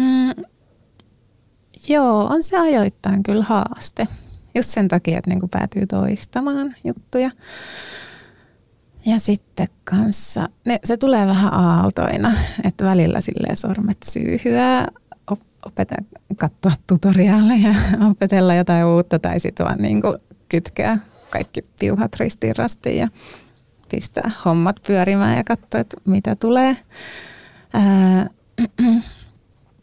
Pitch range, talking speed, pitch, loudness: 175-225 Hz, 105 wpm, 200 Hz, -18 LUFS